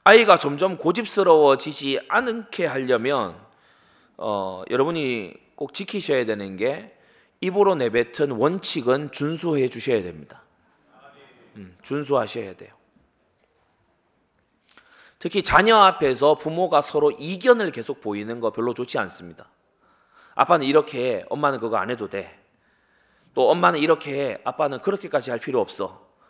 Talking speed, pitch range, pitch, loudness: 280 characters per minute, 115-185 Hz, 145 Hz, -21 LUFS